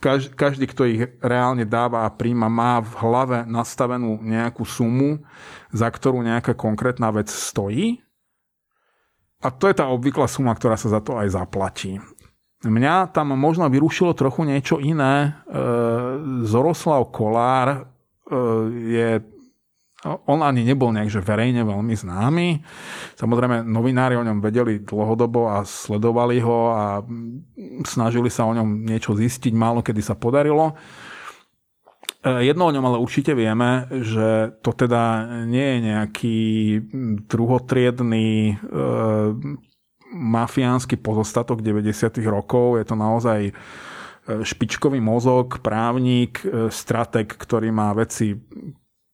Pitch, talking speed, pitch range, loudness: 120 Hz, 115 wpm, 110-130 Hz, -21 LUFS